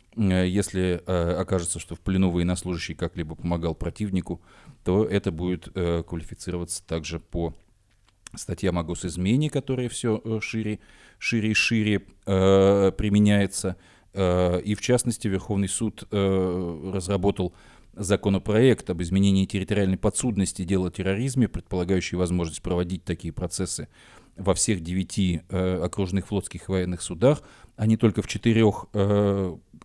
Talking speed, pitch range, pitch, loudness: 130 wpm, 90-105 Hz, 95 Hz, -25 LUFS